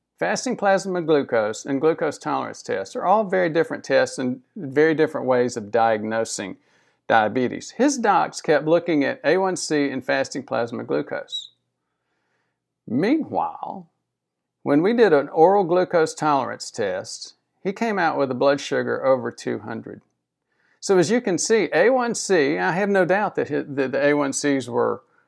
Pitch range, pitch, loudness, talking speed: 130-190 Hz, 150 Hz, -21 LUFS, 145 wpm